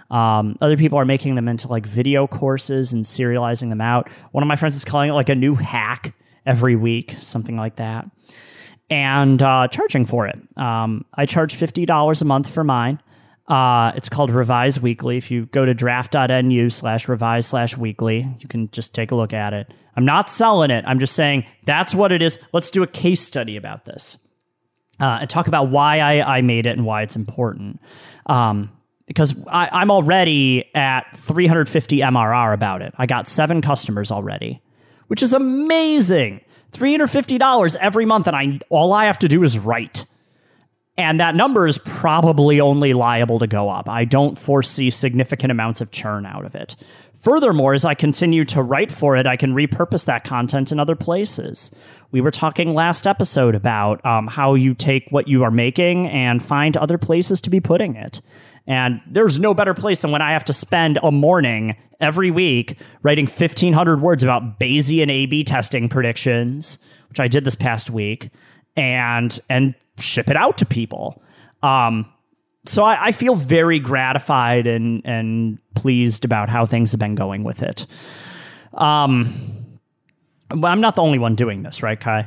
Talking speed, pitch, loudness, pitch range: 185 wpm, 135 Hz, -17 LUFS, 120-155 Hz